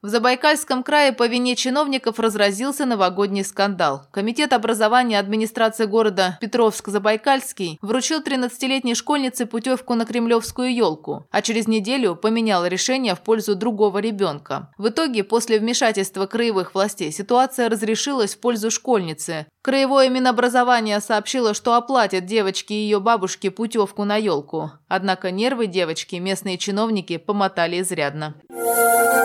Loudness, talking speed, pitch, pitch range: -20 LUFS, 120 wpm, 220 Hz, 195-245 Hz